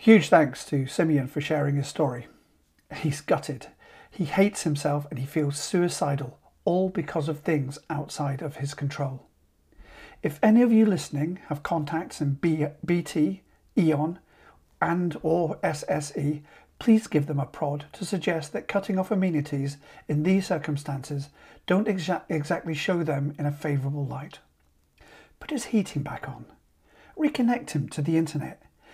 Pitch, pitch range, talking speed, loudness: 155 Hz, 145-180 Hz, 145 wpm, -27 LUFS